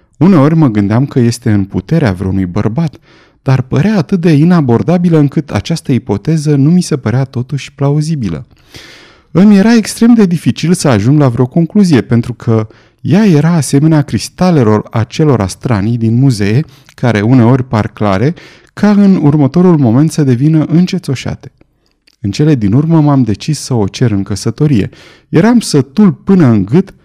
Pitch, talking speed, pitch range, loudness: 140 Hz, 155 wpm, 115-165 Hz, -10 LUFS